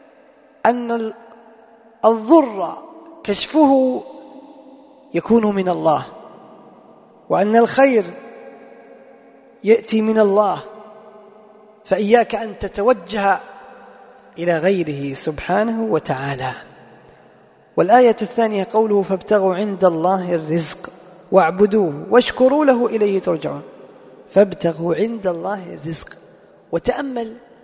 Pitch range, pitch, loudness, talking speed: 185-235 Hz, 215 Hz, -18 LUFS, 75 wpm